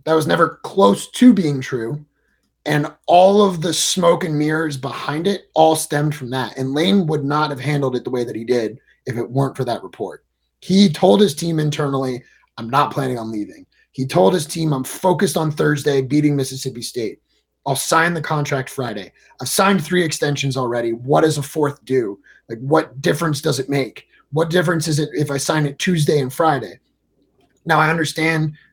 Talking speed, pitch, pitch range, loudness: 195 wpm, 150 Hz, 135-160 Hz, -18 LUFS